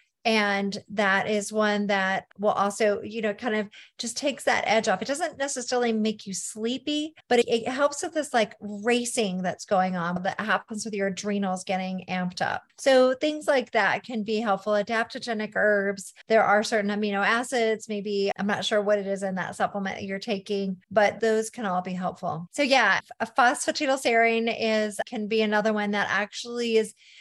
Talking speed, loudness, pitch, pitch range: 190 wpm, -26 LUFS, 215 Hz, 200-235 Hz